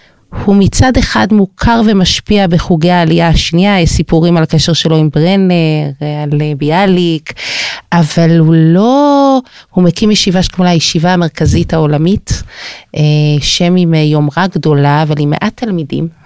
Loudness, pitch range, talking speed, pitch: -10 LUFS, 155-185 Hz, 130 wpm, 170 Hz